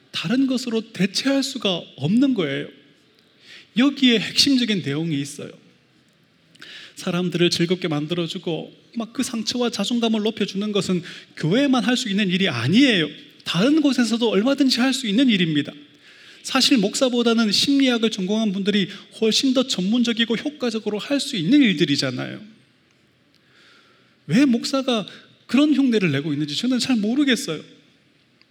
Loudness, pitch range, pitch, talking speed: -20 LUFS, 185-255 Hz, 225 Hz, 310 characters per minute